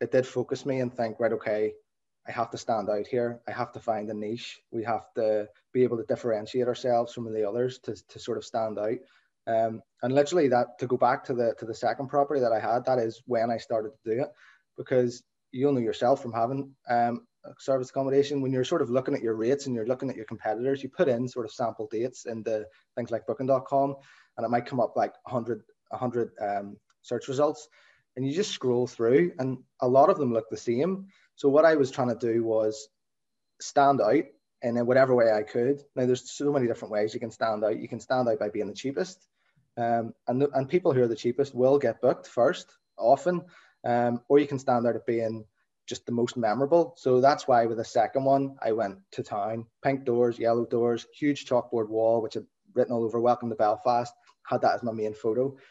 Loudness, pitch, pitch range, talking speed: -27 LUFS, 120 Hz, 115-135 Hz, 230 wpm